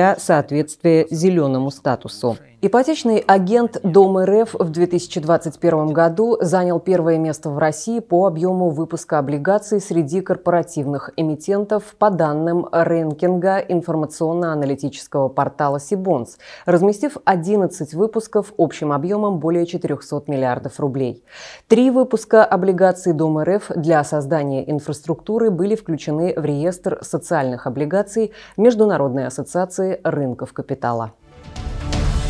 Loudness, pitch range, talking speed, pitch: -18 LUFS, 145-195 Hz, 100 wpm, 170 Hz